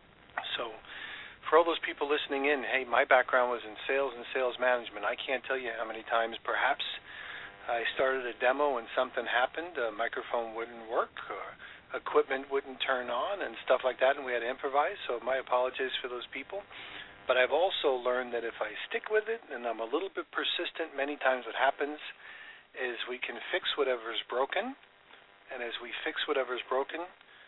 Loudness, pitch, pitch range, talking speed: -32 LUFS, 130 Hz, 120-140 Hz, 190 wpm